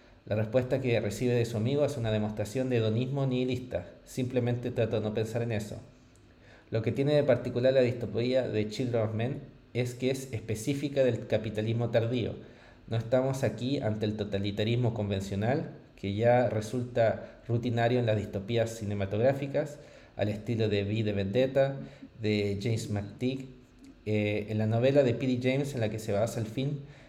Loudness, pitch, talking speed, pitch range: -30 LUFS, 120 Hz, 170 wpm, 110-130 Hz